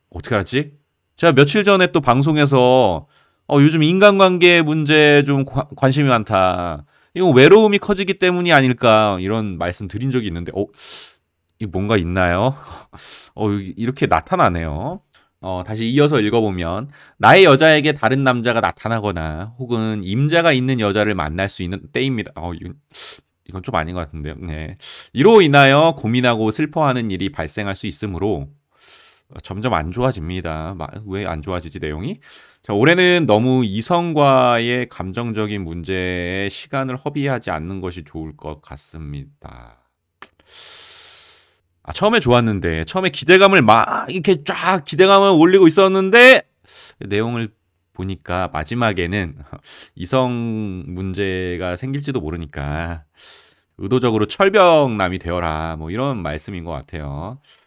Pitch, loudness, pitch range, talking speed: 110 Hz, -16 LUFS, 90-140 Hz, 300 characters per minute